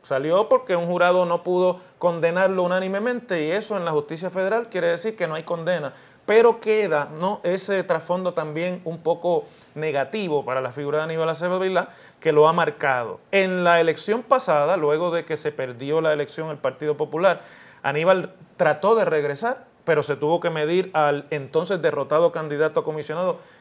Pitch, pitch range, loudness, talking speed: 170 Hz, 155-185 Hz, -22 LUFS, 175 wpm